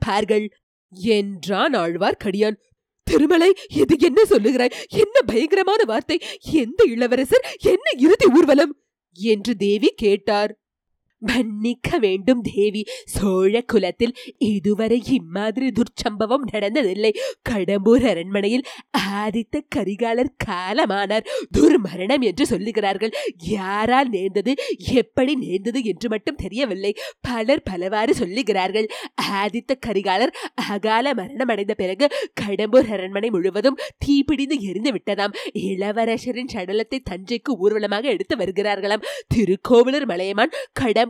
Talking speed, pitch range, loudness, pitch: 95 wpm, 205-280 Hz, -20 LUFS, 235 Hz